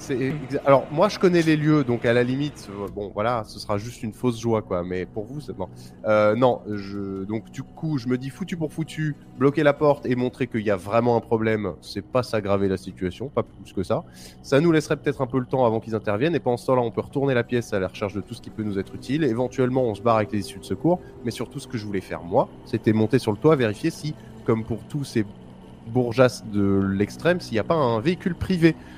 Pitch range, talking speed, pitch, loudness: 105-135 Hz, 265 wpm, 120 Hz, -24 LUFS